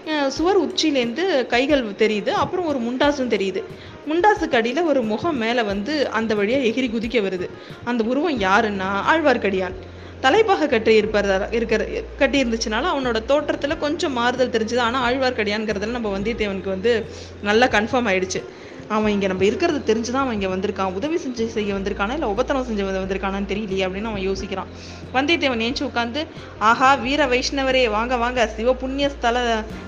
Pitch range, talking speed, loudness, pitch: 210-275 Hz, 140 wpm, -21 LUFS, 235 Hz